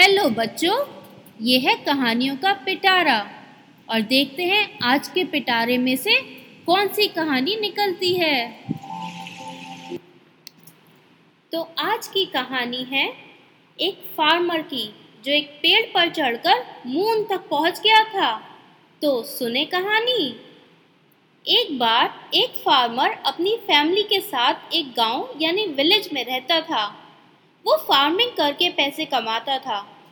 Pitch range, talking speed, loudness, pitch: 255-390 Hz, 125 wpm, -20 LUFS, 310 Hz